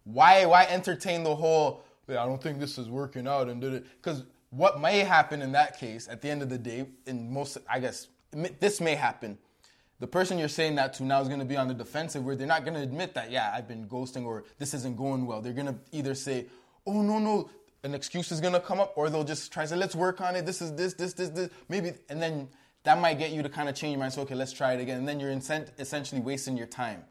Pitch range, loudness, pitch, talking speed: 130-170 Hz, -29 LUFS, 145 Hz, 270 wpm